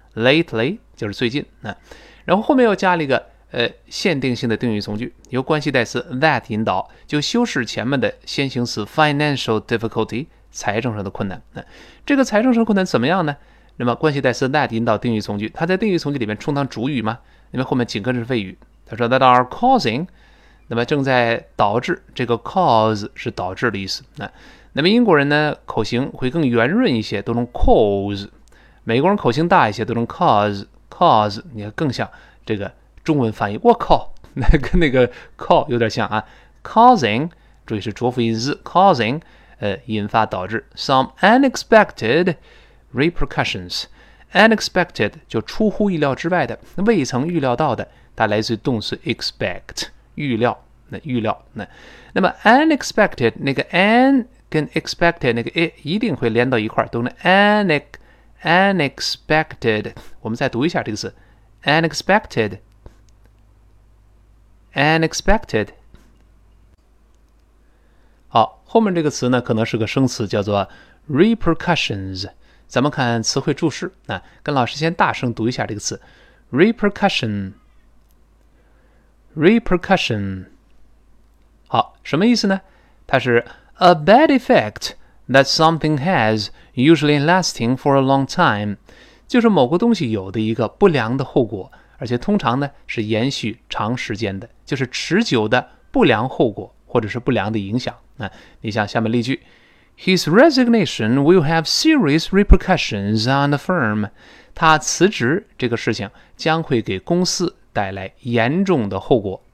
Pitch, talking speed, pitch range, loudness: 130 Hz, 355 characters per minute, 110-170 Hz, -18 LUFS